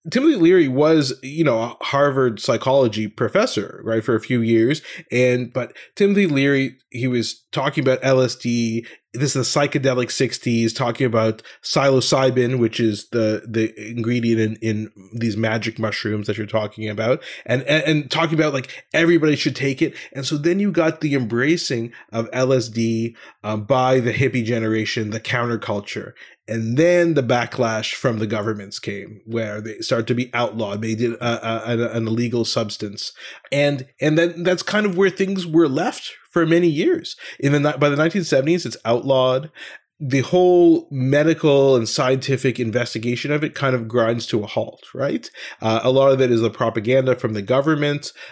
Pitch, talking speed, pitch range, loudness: 125 Hz, 175 wpm, 115-145 Hz, -20 LUFS